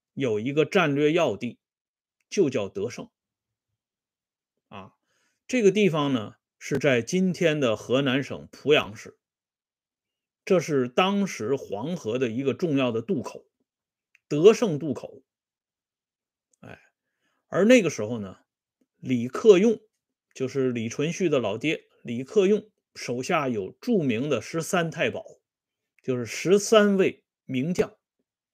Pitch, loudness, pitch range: 150 Hz, -24 LUFS, 125-200 Hz